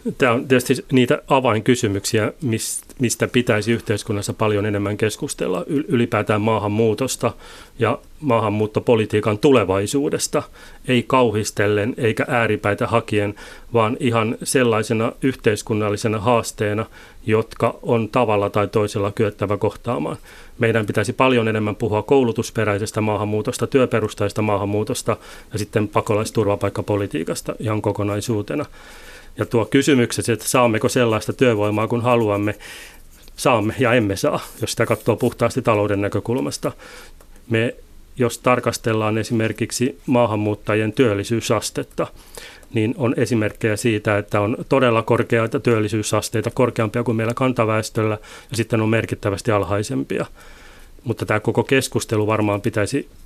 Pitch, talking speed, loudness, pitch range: 110 Hz, 110 wpm, -20 LUFS, 105-120 Hz